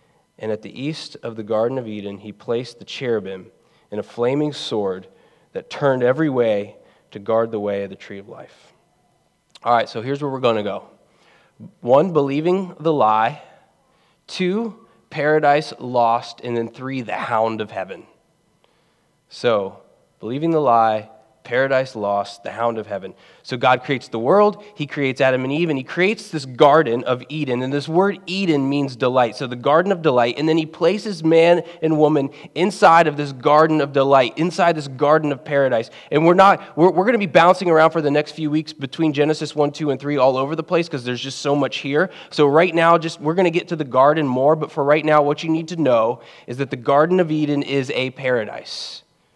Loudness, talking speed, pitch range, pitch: -19 LUFS, 205 wpm, 125-160 Hz, 145 Hz